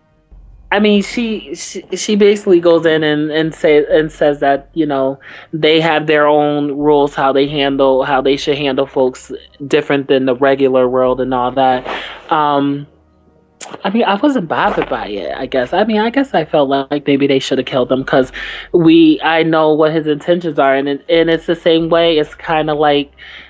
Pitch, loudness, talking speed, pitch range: 150 Hz, -13 LUFS, 200 wpm, 135-165 Hz